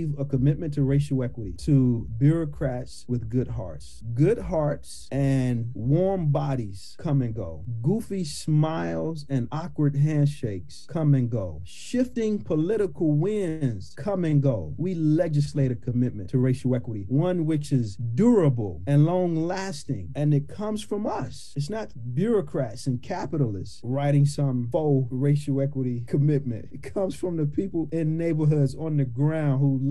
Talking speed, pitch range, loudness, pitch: 150 wpm, 125-160 Hz, -26 LUFS, 140 Hz